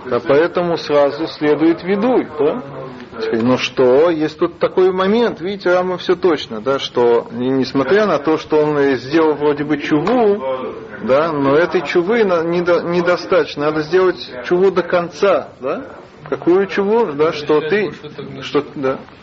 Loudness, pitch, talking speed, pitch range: -16 LUFS, 160 Hz, 145 wpm, 140-185 Hz